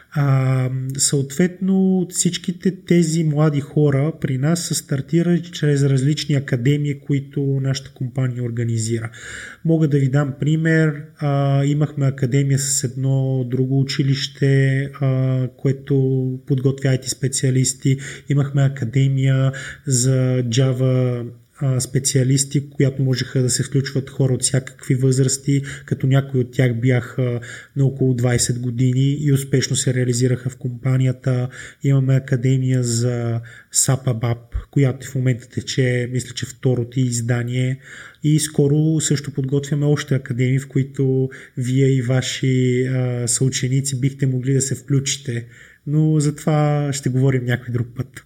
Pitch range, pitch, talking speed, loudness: 130-140 Hz, 135 Hz, 125 wpm, -19 LUFS